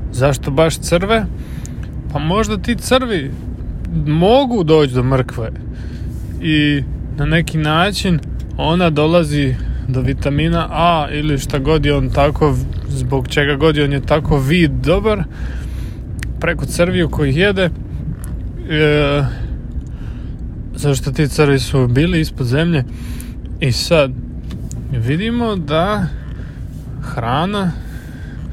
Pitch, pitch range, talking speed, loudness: 150 Hz, 135-165 Hz, 110 wpm, -16 LUFS